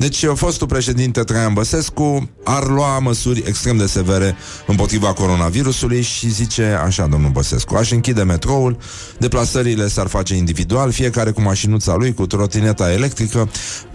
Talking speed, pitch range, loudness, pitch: 140 wpm, 100-125 Hz, -17 LUFS, 115 Hz